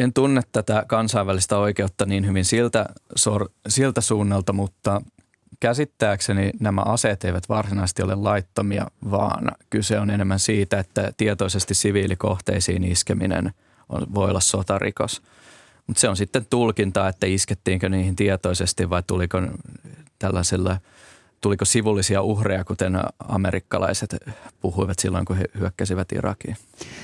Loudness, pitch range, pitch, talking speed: -22 LUFS, 95-110 Hz, 100 Hz, 120 wpm